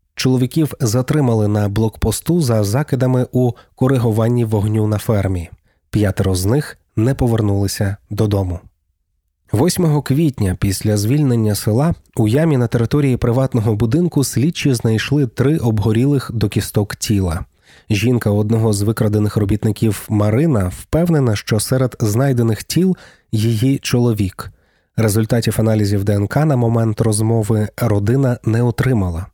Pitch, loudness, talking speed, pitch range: 115 Hz, -17 LUFS, 115 wpm, 105-130 Hz